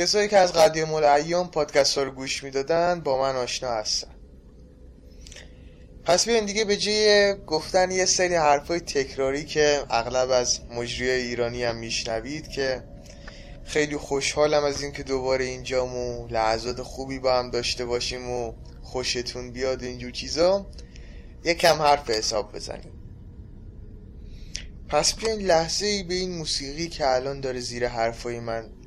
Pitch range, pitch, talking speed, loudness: 115-155 Hz, 130 Hz, 145 wpm, -24 LUFS